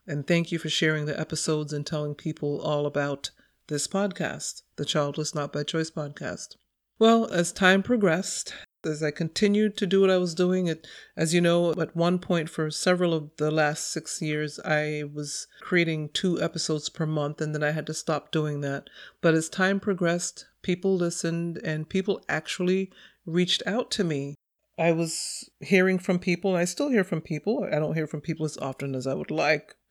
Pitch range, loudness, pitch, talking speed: 150-180 Hz, -27 LUFS, 160 Hz, 195 wpm